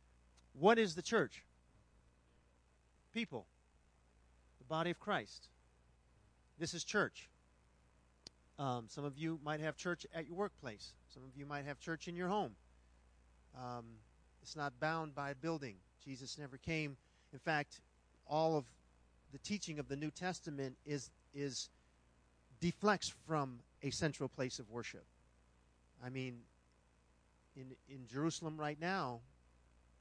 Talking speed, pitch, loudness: 135 wpm, 130 Hz, -42 LUFS